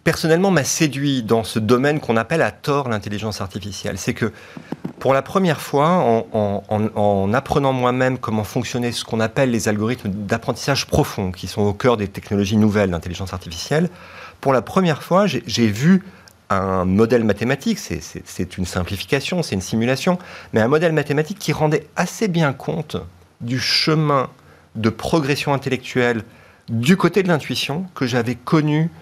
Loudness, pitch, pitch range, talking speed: -19 LUFS, 125 Hz, 105-150 Hz, 165 wpm